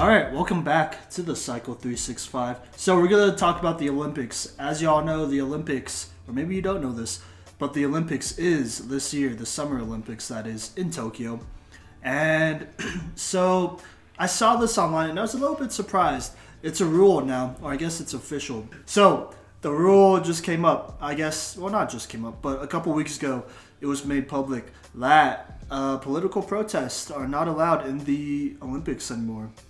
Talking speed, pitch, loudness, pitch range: 190 wpm, 145 Hz, -25 LUFS, 125-170 Hz